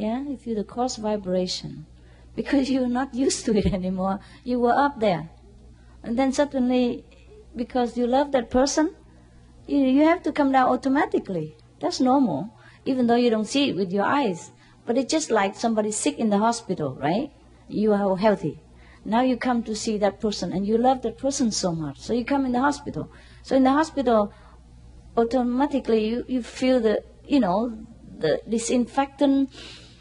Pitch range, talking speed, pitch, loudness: 200-265 Hz, 180 wpm, 240 Hz, -24 LUFS